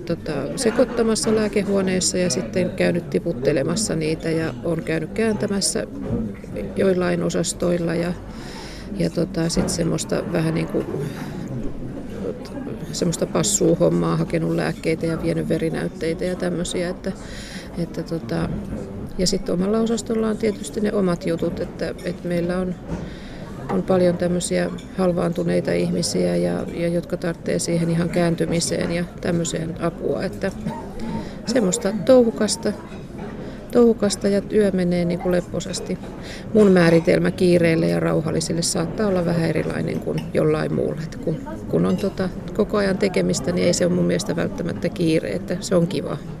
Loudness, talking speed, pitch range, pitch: -22 LUFS, 135 wpm, 165-195 Hz, 175 Hz